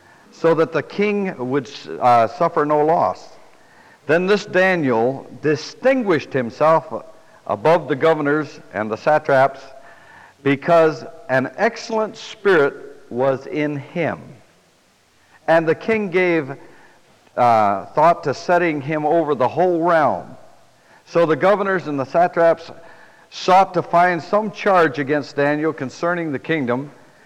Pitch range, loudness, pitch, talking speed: 145-180 Hz, -18 LUFS, 160 Hz, 125 wpm